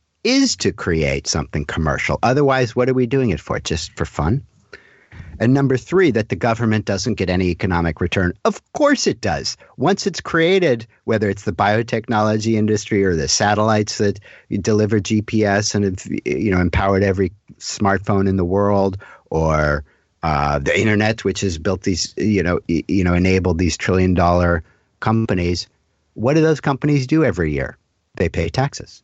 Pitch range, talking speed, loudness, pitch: 90-115 Hz, 165 wpm, -18 LUFS, 100 Hz